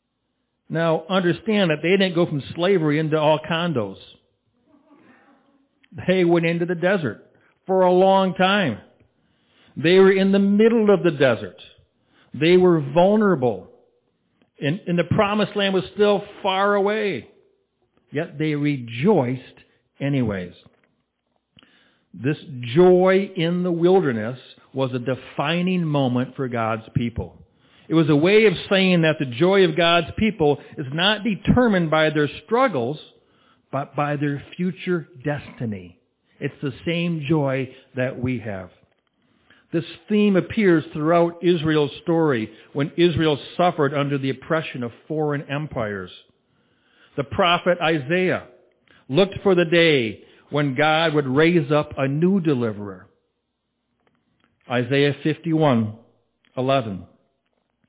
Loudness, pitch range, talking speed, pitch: -20 LUFS, 135-185 Hz, 120 wpm, 160 Hz